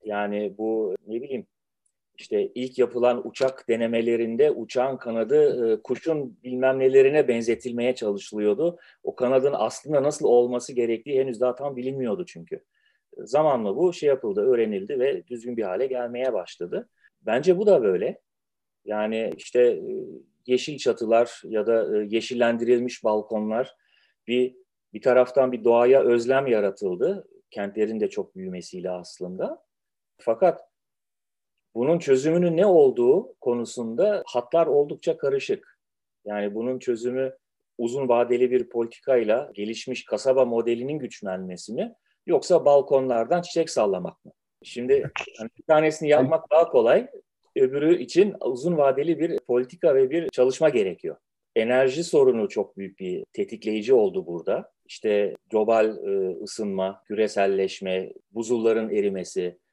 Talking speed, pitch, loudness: 120 wpm, 130 Hz, -24 LUFS